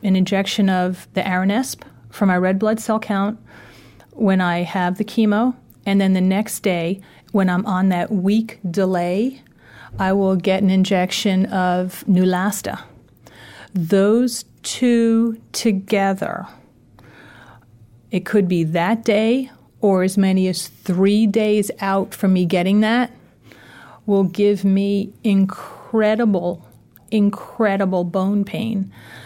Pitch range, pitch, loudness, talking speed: 180-210 Hz, 195 Hz, -19 LUFS, 125 wpm